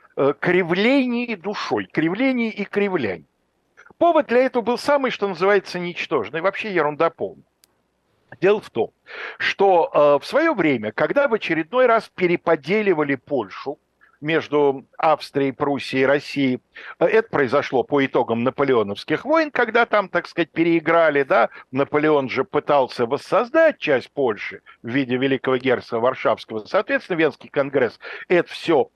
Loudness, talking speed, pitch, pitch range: -20 LUFS, 130 wpm, 165 Hz, 140-220 Hz